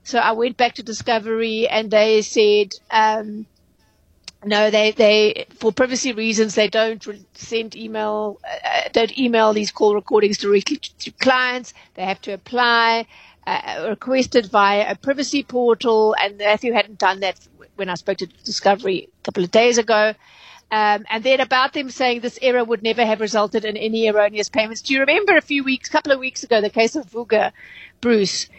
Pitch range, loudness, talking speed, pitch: 210-245 Hz, -18 LUFS, 180 wpm, 220 Hz